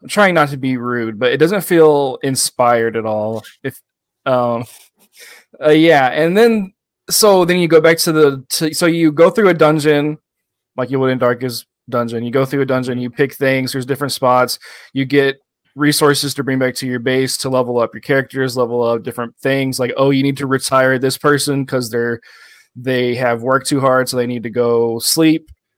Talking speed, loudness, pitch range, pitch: 205 wpm, -15 LUFS, 125-150 Hz, 135 Hz